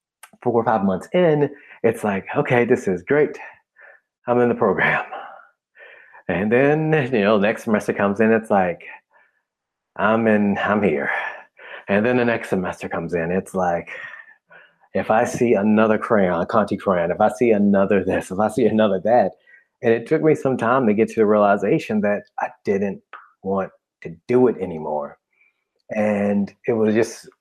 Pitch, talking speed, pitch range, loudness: 110 Hz, 175 wpm, 100-125 Hz, -20 LUFS